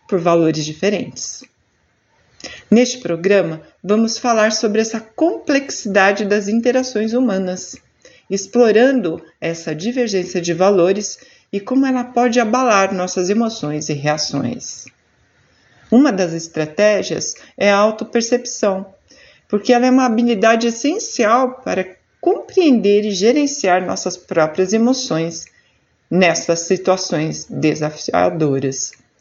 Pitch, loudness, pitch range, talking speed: 205 Hz, -16 LUFS, 175-240 Hz, 100 wpm